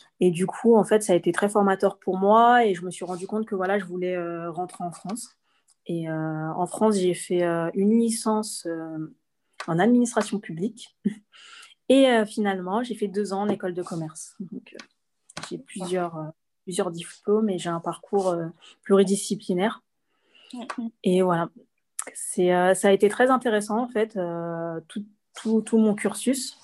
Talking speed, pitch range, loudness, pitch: 180 wpm, 175-215 Hz, -24 LUFS, 195 Hz